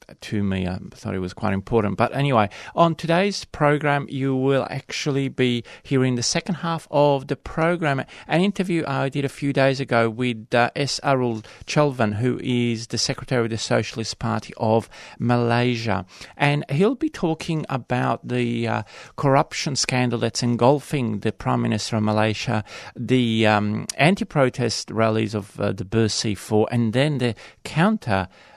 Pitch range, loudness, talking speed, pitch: 110-140 Hz, -22 LUFS, 155 wpm, 125 Hz